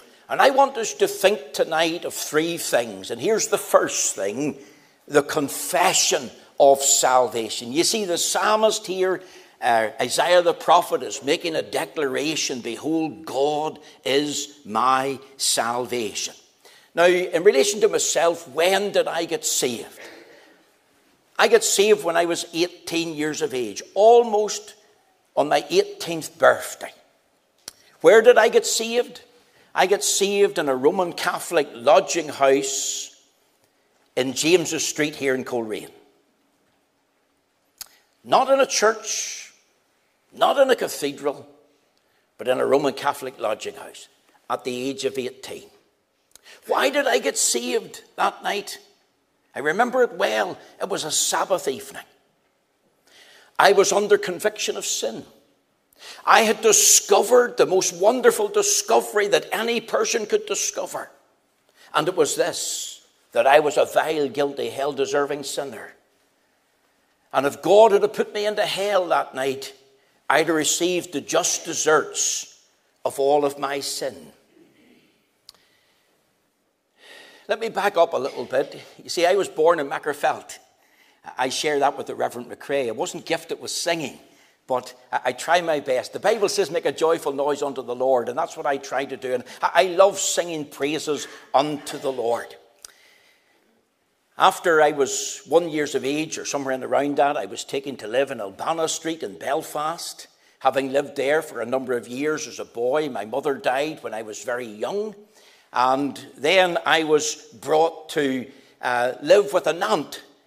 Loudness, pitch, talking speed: -21 LUFS, 170 Hz, 150 wpm